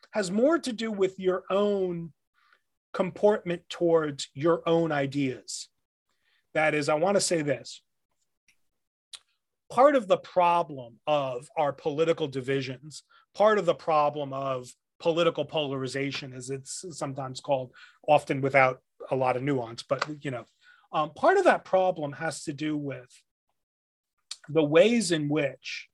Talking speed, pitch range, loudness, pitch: 140 wpm, 135-180 Hz, -27 LUFS, 155 Hz